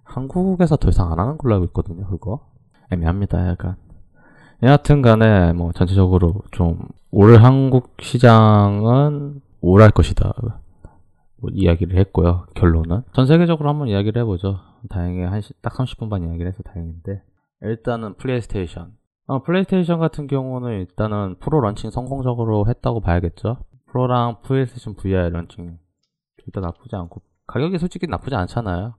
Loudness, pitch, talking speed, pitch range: -18 LUFS, 105 Hz, 350 characters per minute, 90-125 Hz